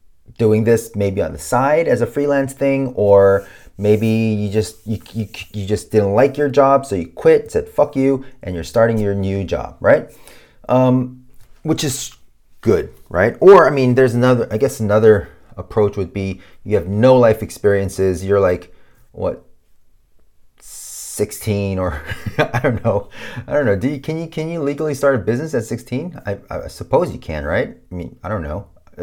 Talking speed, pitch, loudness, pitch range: 185 wpm, 110 Hz, -17 LUFS, 100-130 Hz